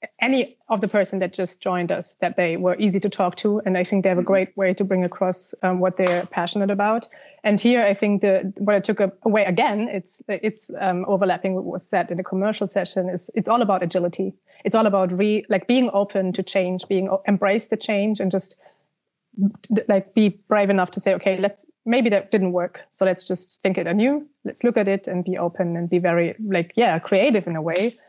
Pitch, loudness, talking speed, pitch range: 195 Hz, -22 LUFS, 225 wpm, 185-210 Hz